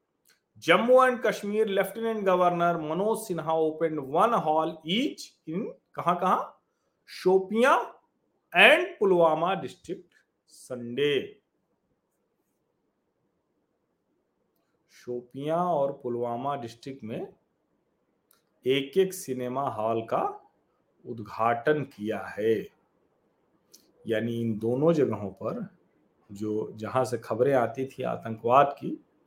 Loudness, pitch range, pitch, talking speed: -26 LUFS, 120-200 Hz, 155 Hz, 90 wpm